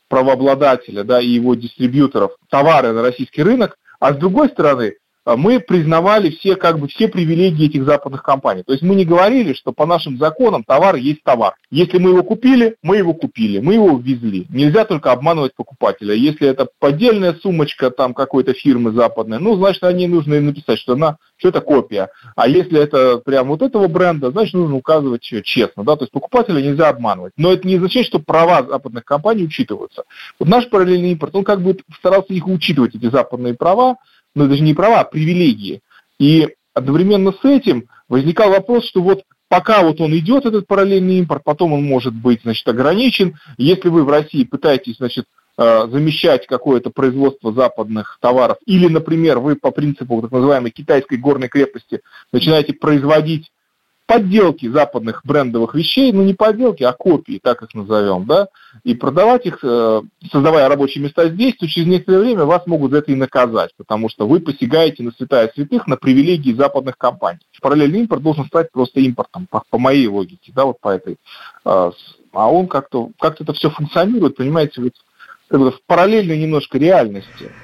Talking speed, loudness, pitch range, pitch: 175 wpm, -14 LUFS, 130-185 Hz, 155 Hz